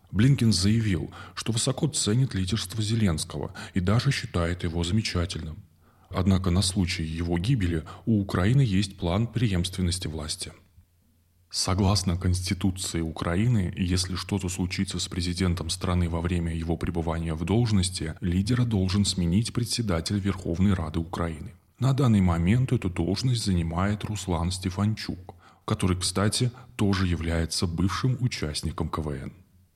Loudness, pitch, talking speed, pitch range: -26 LUFS, 95 Hz, 120 wpm, 85-105 Hz